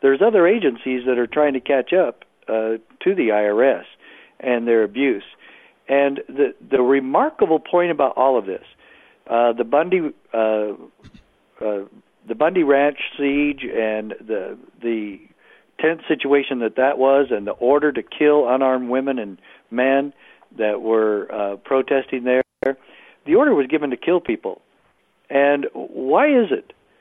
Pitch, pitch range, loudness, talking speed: 135 Hz, 115-145 Hz, -19 LUFS, 150 wpm